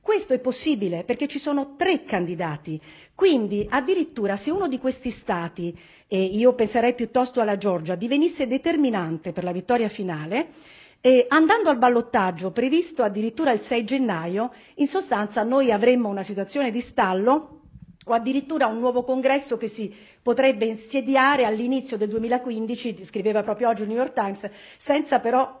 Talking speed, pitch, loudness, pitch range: 150 wpm, 240 Hz, -23 LUFS, 205-270 Hz